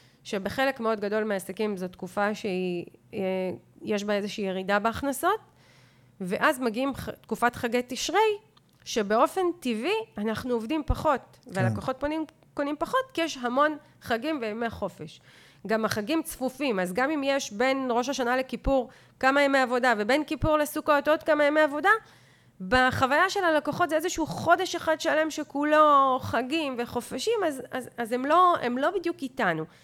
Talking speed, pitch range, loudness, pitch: 145 wpm, 220-310 Hz, -26 LUFS, 260 Hz